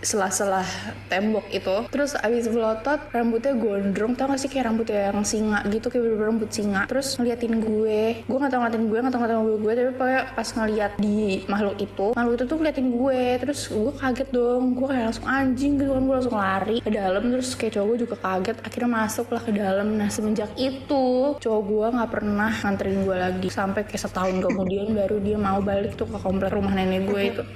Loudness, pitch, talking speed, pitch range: -24 LUFS, 220 Hz, 205 wpm, 205-250 Hz